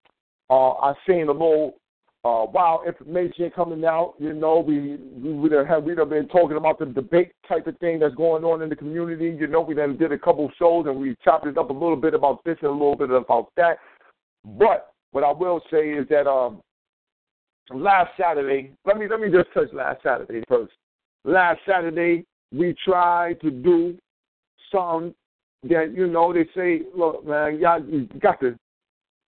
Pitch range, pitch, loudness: 145-170 Hz, 160 Hz, -22 LUFS